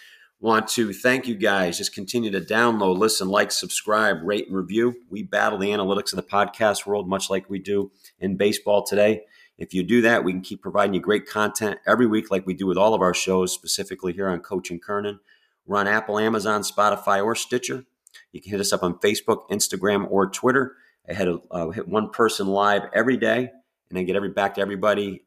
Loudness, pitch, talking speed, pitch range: -22 LUFS, 100 Hz, 210 wpm, 95-110 Hz